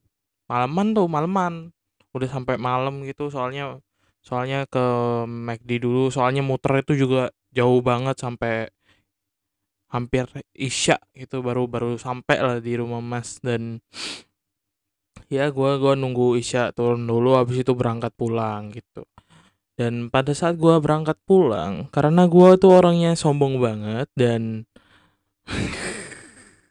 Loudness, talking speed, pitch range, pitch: -21 LUFS, 125 wpm, 115-135 Hz, 125 Hz